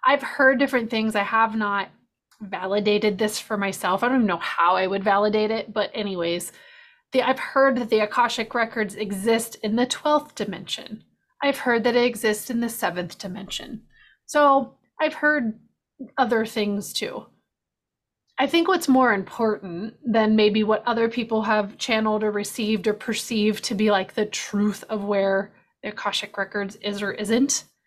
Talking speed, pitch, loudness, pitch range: 170 wpm, 220 Hz, -23 LUFS, 205-245 Hz